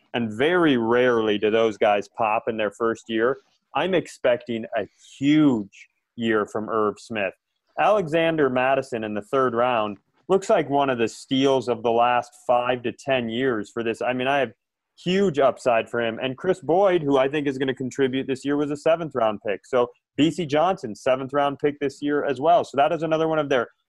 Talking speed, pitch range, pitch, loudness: 205 wpm, 115-150 Hz, 130 Hz, -23 LUFS